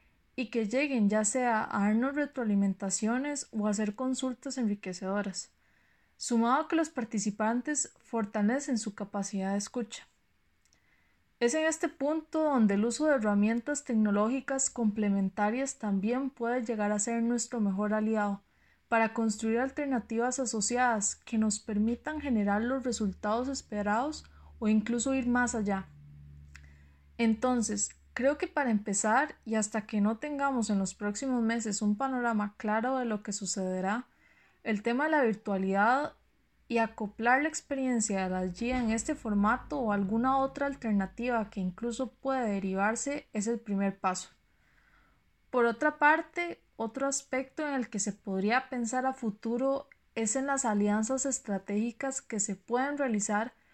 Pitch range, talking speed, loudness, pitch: 205-260 Hz, 145 wpm, -31 LUFS, 225 Hz